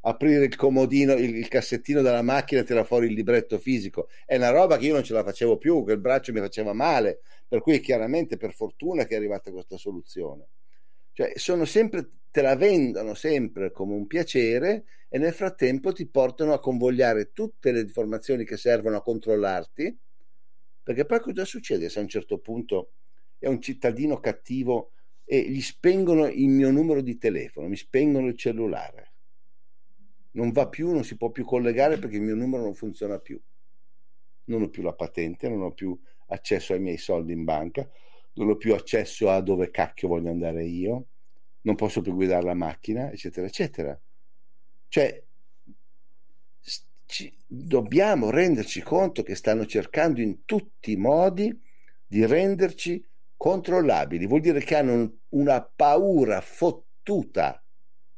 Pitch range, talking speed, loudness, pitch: 110-155 Hz, 165 wpm, -25 LUFS, 125 Hz